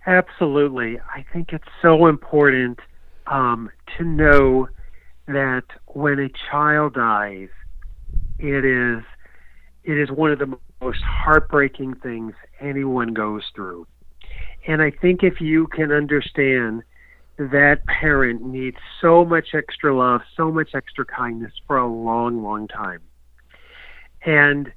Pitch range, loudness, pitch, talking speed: 115-150 Hz, -19 LUFS, 135 Hz, 125 wpm